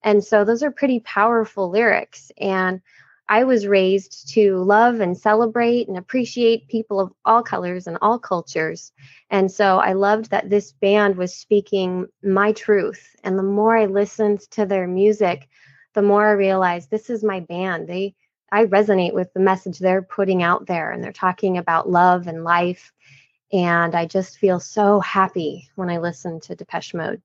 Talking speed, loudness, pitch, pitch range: 175 wpm, -19 LUFS, 195 Hz, 180-210 Hz